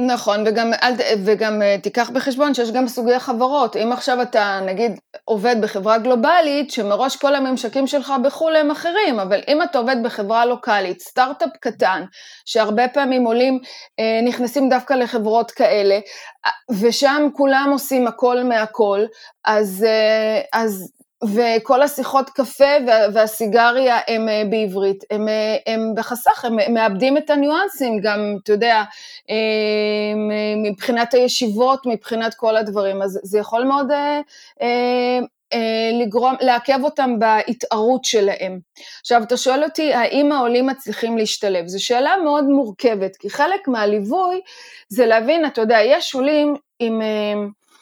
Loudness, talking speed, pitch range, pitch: -18 LUFS, 125 wpm, 215-270 Hz, 240 Hz